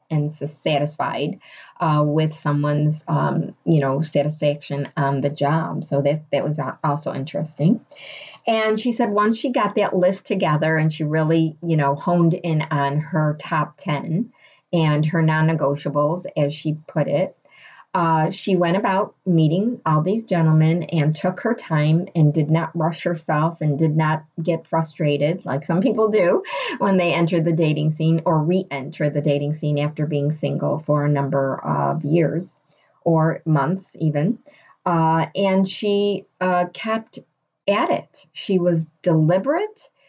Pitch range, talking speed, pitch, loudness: 150-180 Hz, 155 wpm, 160 Hz, -21 LUFS